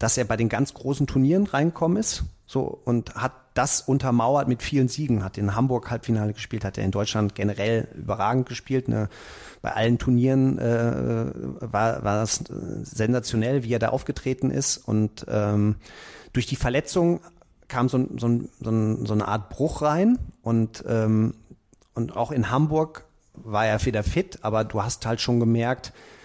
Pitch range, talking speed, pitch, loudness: 110-135 Hz, 165 wpm, 120 Hz, -25 LUFS